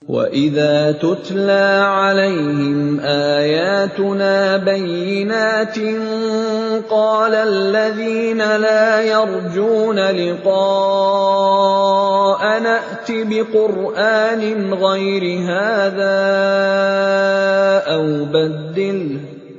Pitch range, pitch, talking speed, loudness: 190-215 Hz, 195 Hz, 50 wpm, -16 LUFS